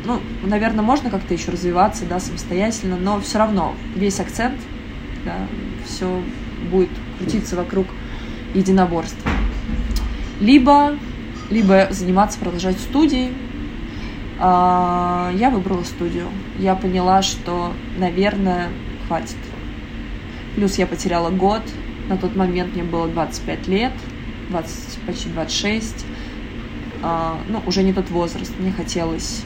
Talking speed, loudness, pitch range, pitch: 110 wpm, -20 LUFS, 175-210 Hz, 190 Hz